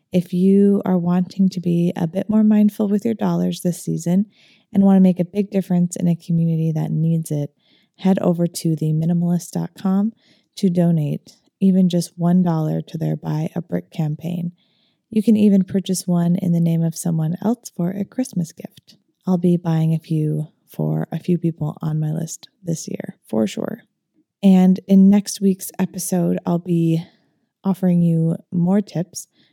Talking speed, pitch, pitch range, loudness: 175 wpm, 175 Hz, 165-195 Hz, -19 LUFS